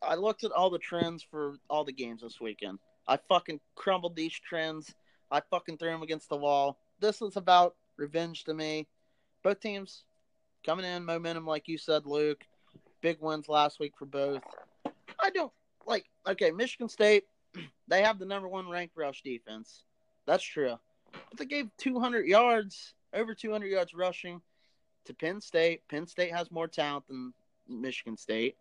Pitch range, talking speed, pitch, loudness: 150-195 Hz, 170 wpm, 165 Hz, -32 LUFS